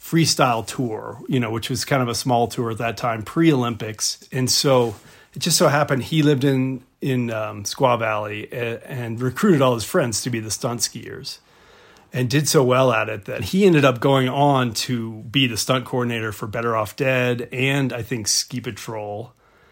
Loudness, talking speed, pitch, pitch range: -20 LUFS, 200 wpm, 125 Hz, 115-135 Hz